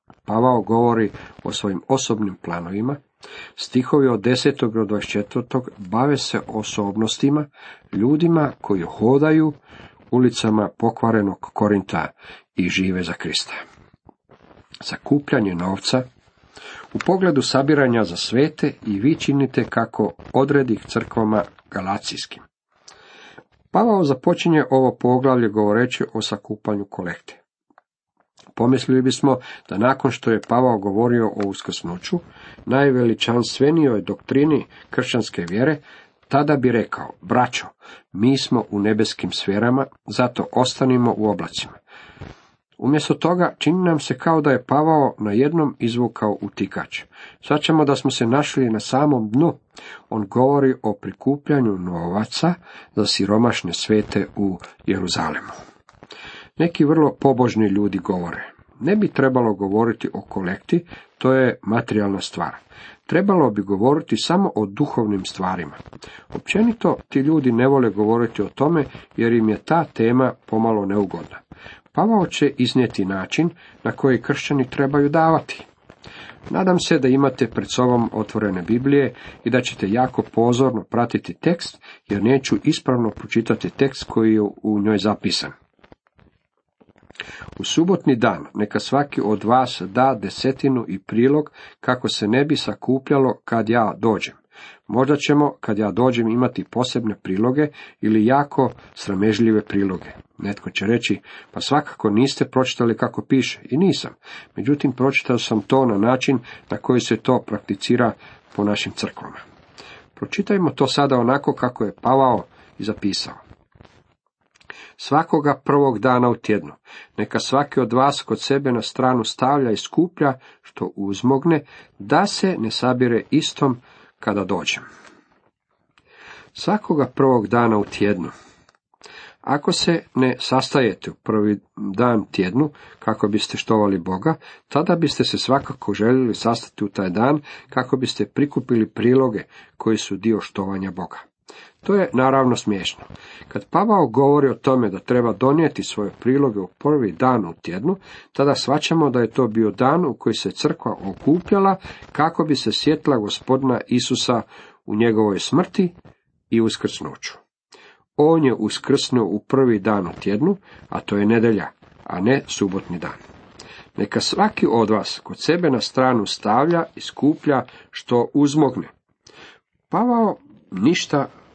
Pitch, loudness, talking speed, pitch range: 125 Hz, -20 LUFS, 130 wpm, 105-140 Hz